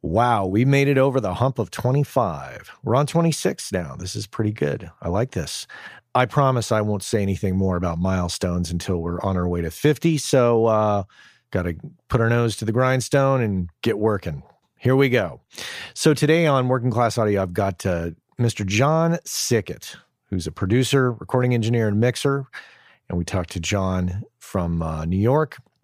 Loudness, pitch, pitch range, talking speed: -22 LUFS, 110 Hz, 95-130 Hz, 185 wpm